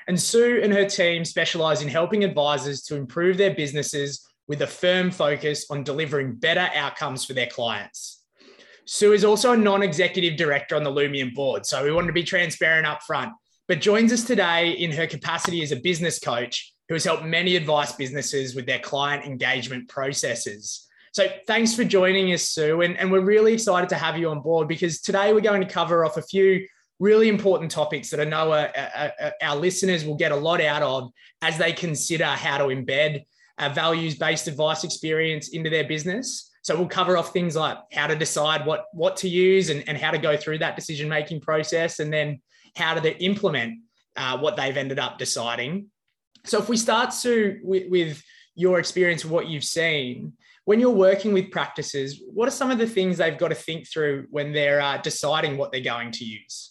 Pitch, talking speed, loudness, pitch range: 160 Hz, 200 wpm, -23 LUFS, 145-185 Hz